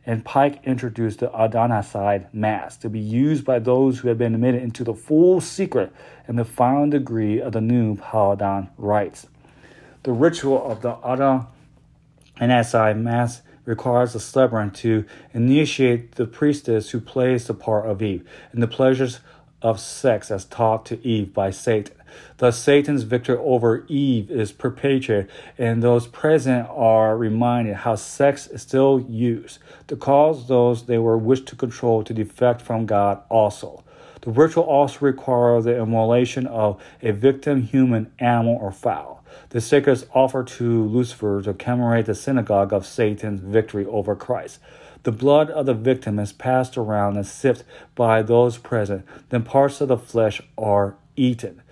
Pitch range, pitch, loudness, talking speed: 110-130 Hz, 120 Hz, -20 LUFS, 160 wpm